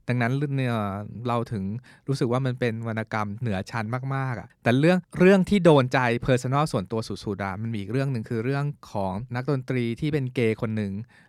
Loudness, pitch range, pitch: -25 LUFS, 110-135 Hz, 120 Hz